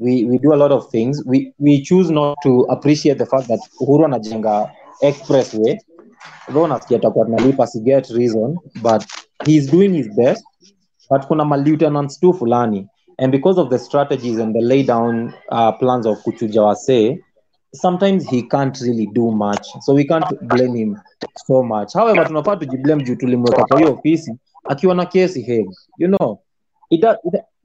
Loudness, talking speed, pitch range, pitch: -16 LUFS, 165 wpm, 120-155 Hz, 135 Hz